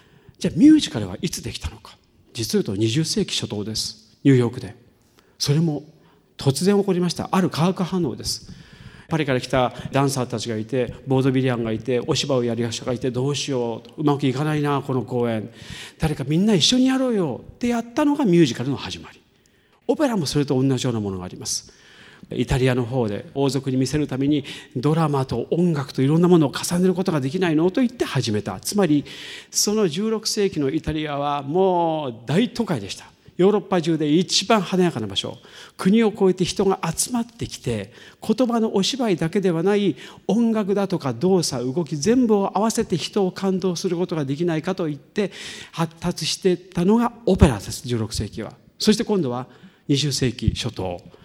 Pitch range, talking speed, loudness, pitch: 130-190 Hz, 375 characters per minute, -22 LUFS, 155 Hz